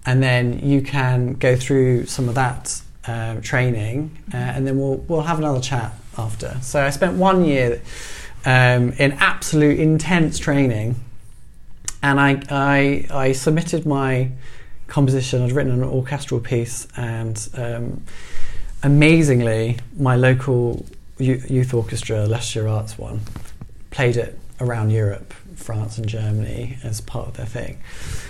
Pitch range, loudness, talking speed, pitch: 115-140 Hz, -20 LUFS, 135 wpm, 125 Hz